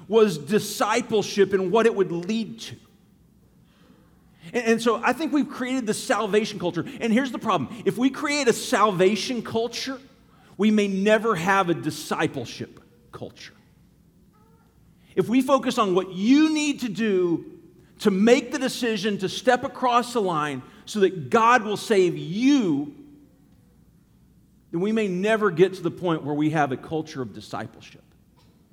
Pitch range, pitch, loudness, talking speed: 180-245 Hz, 210 Hz, -23 LUFS, 155 wpm